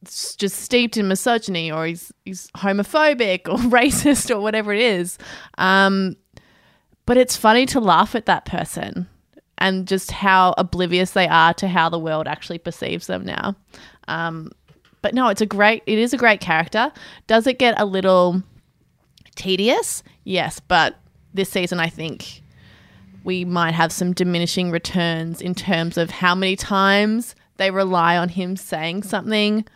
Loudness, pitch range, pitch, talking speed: -19 LUFS, 170-215 Hz, 190 Hz, 155 wpm